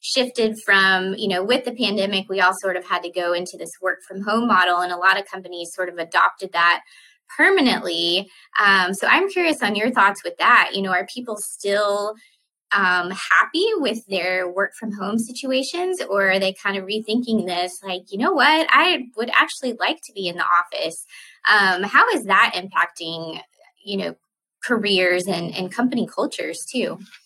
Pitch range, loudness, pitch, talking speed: 185-240 Hz, -19 LUFS, 200 Hz, 185 wpm